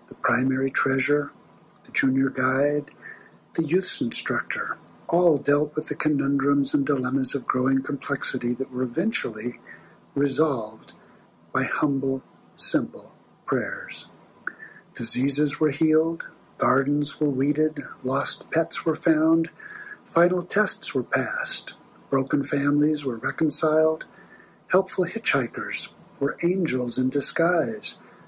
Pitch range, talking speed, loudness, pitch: 135-155 Hz, 110 wpm, -24 LUFS, 145 Hz